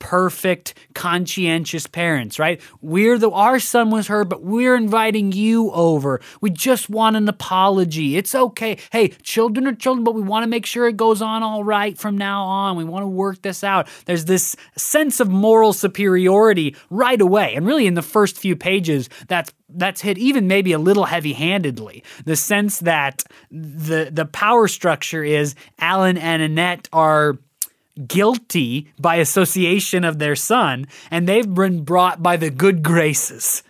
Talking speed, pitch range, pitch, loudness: 170 wpm, 165-215 Hz, 190 Hz, -18 LUFS